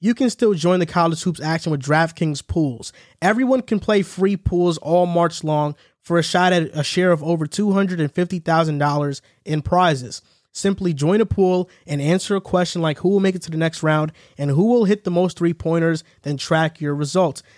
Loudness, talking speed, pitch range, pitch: -20 LUFS, 200 wpm, 155-185 Hz, 170 Hz